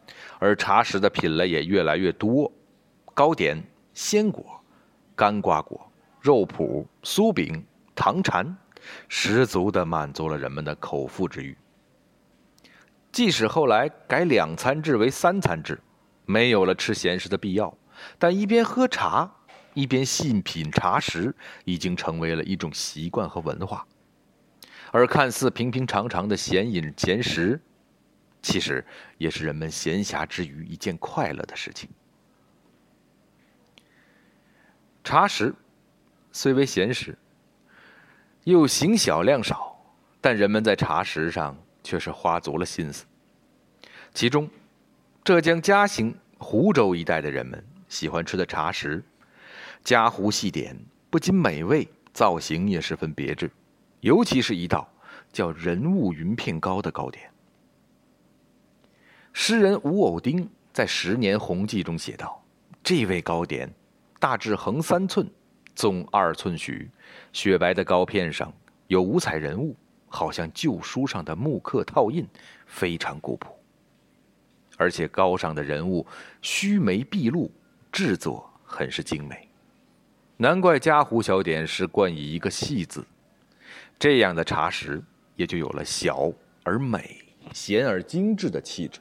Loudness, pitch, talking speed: -24 LUFS, 110 Hz, 190 characters per minute